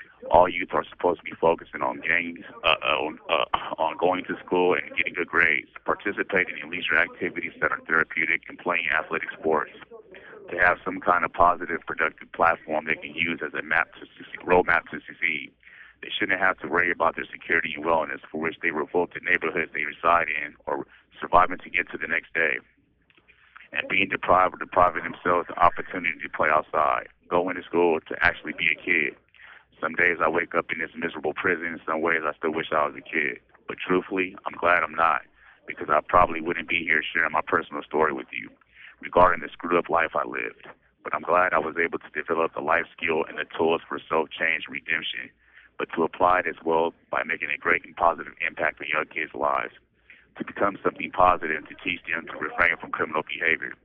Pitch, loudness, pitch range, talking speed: 85 Hz, -25 LUFS, 75-90 Hz, 210 wpm